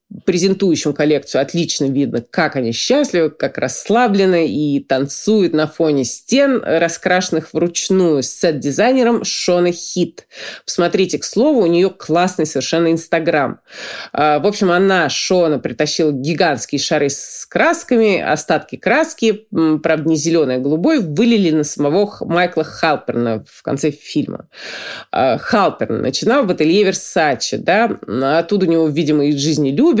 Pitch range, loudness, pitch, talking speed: 150-190 Hz, -16 LUFS, 165 Hz, 130 wpm